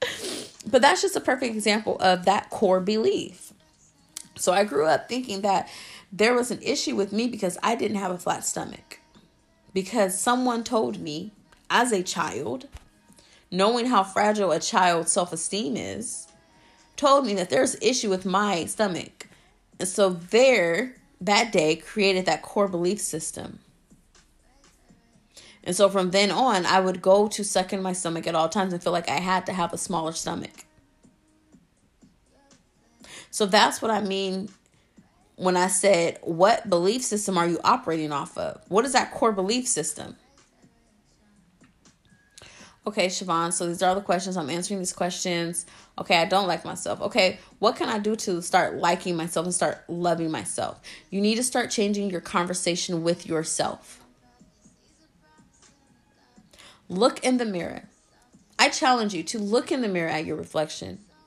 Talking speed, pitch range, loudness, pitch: 160 wpm, 175-215 Hz, -24 LUFS, 195 Hz